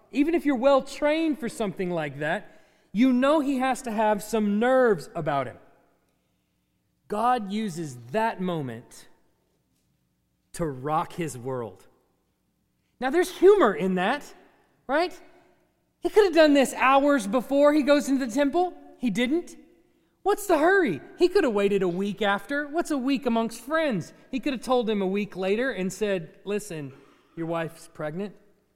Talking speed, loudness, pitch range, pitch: 160 wpm, -25 LUFS, 190-290 Hz, 245 Hz